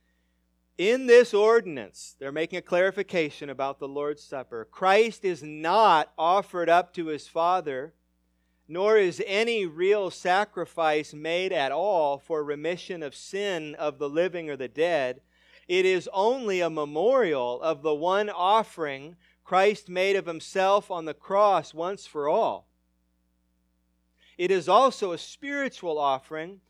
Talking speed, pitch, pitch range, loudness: 140 wpm, 170 Hz, 145-195 Hz, -25 LUFS